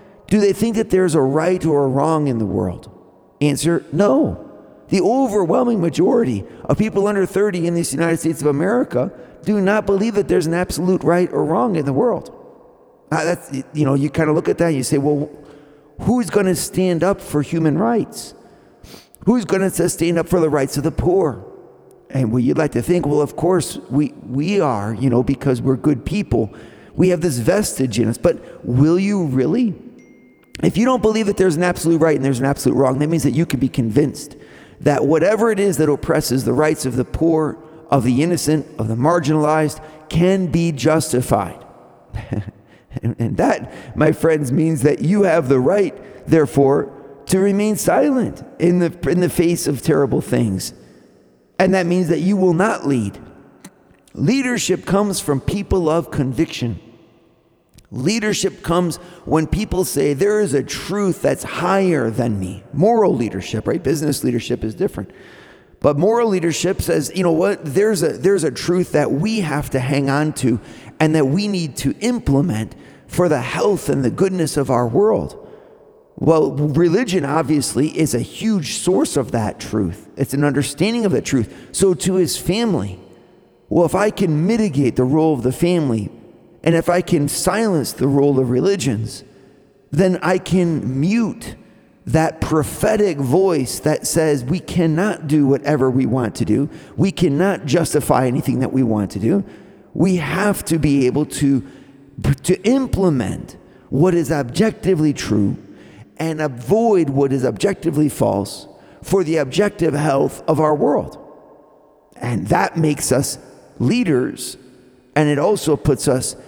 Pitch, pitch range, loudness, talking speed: 155 Hz, 135-185 Hz, -18 LUFS, 170 wpm